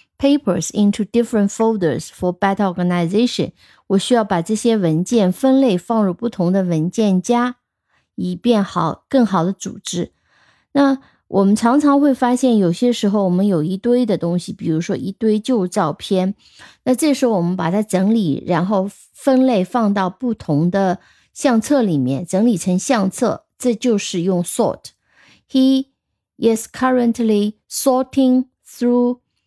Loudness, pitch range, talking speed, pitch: -17 LUFS, 185-245 Hz, 335 characters per minute, 210 Hz